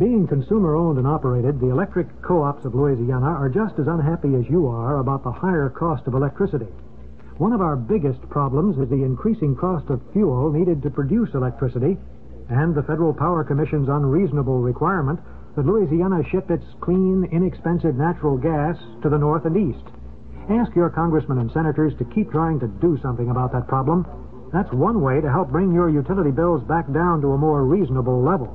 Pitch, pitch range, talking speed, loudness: 150 Hz, 135-170 Hz, 185 wpm, -21 LUFS